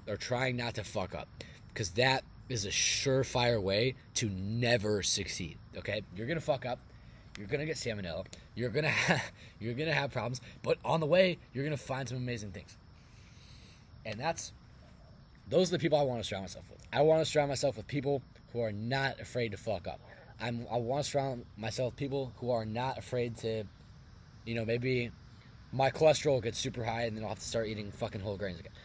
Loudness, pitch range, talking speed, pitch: -33 LUFS, 110-135 Hz, 210 wpm, 120 Hz